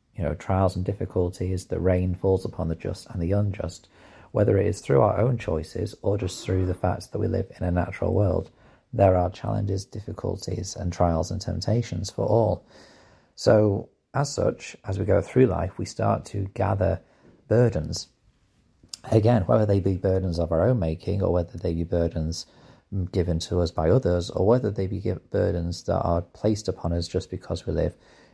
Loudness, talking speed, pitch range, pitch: -25 LUFS, 190 wpm, 85-105 Hz, 95 Hz